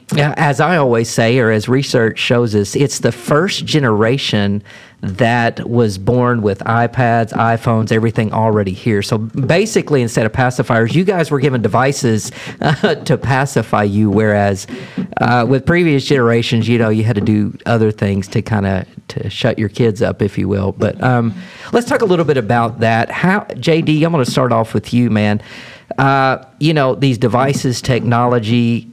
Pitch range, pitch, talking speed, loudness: 110-135 Hz, 120 Hz, 180 wpm, -14 LUFS